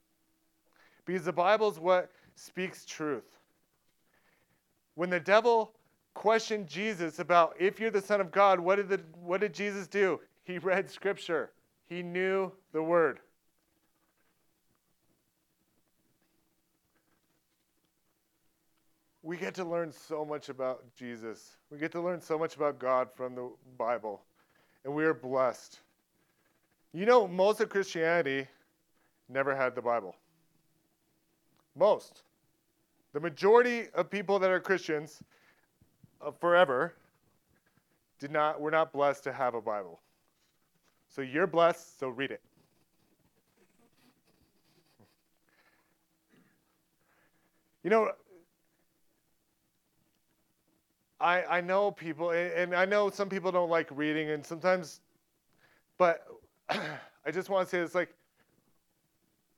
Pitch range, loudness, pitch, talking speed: 155-190 Hz, -30 LUFS, 170 Hz, 115 wpm